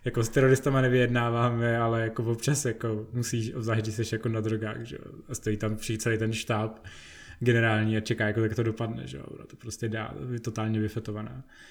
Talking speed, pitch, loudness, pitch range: 190 wpm, 115 Hz, -28 LUFS, 110-120 Hz